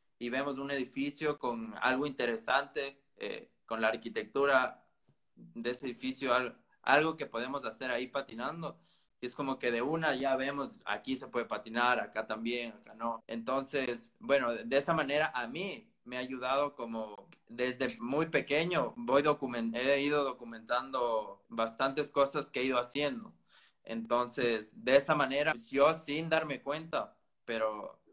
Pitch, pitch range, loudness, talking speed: 130 Hz, 120-145 Hz, -33 LUFS, 155 wpm